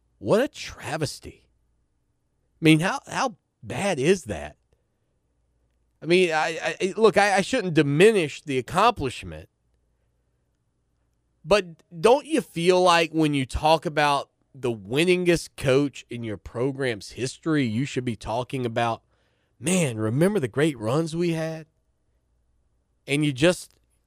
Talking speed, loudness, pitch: 130 wpm, -23 LUFS, 135 Hz